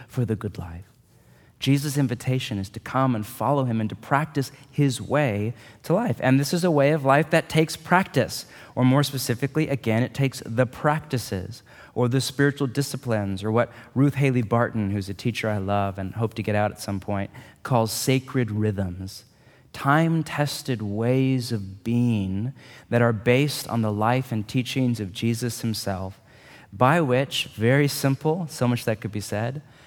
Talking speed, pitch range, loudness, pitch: 175 wpm, 110-140 Hz, -24 LUFS, 125 Hz